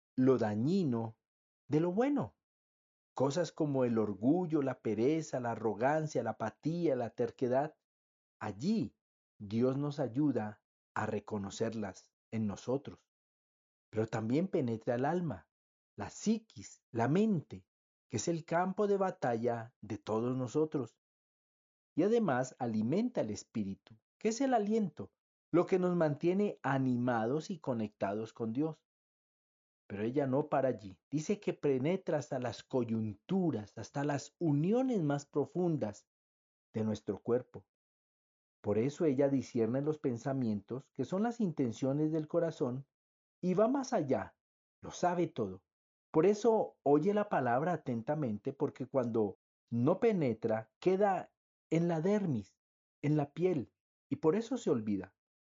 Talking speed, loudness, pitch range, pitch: 130 wpm, -34 LUFS, 110-165 Hz, 130 Hz